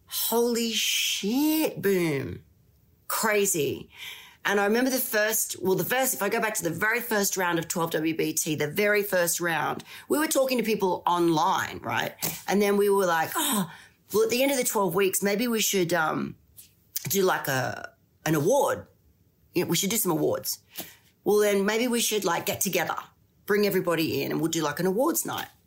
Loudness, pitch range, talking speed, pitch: -25 LUFS, 165-220 Hz, 190 wpm, 200 Hz